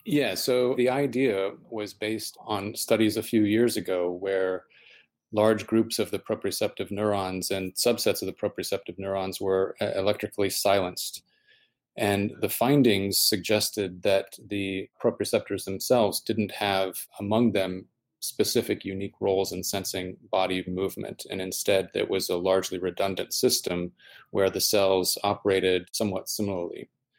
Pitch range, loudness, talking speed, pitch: 95-110 Hz, -27 LUFS, 135 wpm, 100 Hz